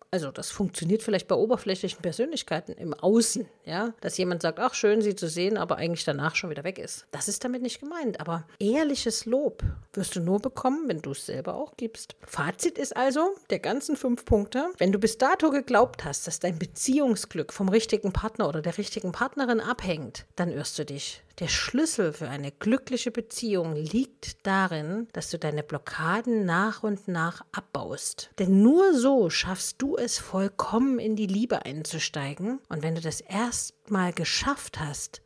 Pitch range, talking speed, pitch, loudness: 170-245 Hz, 180 wpm, 210 Hz, -27 LUFS